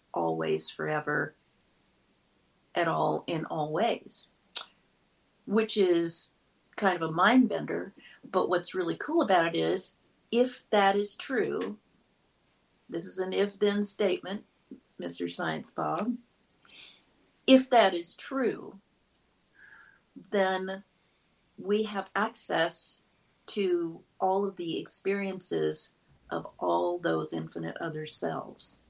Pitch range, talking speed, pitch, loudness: 155-205 Hz, 110 wpm, 190 Hz, -29 LUFS